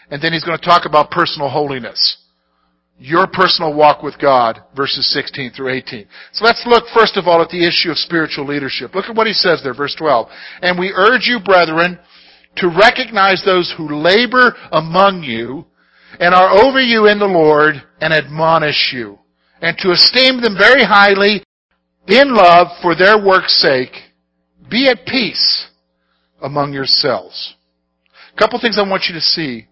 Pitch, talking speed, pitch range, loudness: 170 Hz, 175 wpm, 135-195 Hz, -12 LUFS